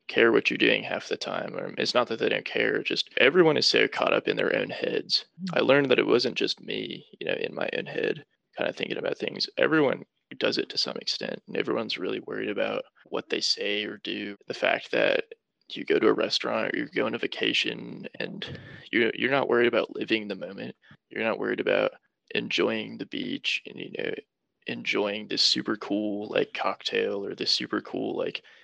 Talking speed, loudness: 210 wpm, -27 LUFS